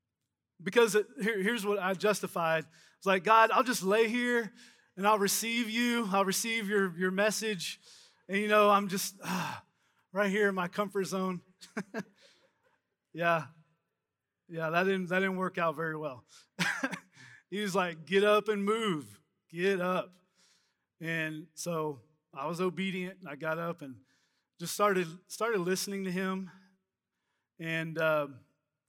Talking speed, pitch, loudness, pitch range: 150 wpm, 190 Hz, -31 LUFS, 165-205 Hz